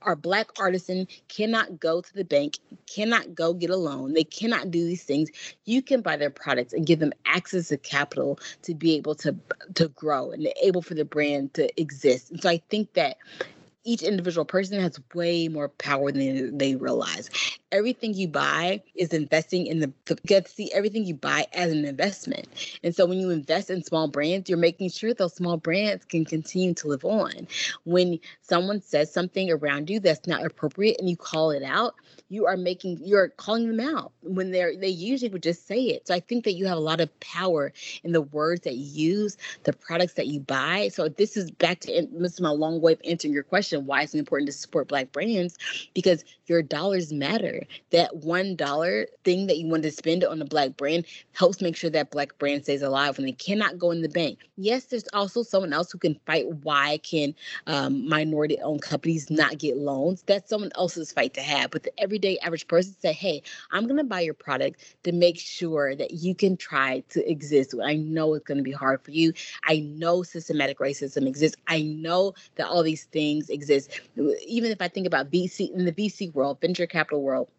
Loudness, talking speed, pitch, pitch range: -26 LUFS, 210 wpm, 170 Hz, 150-185 Hz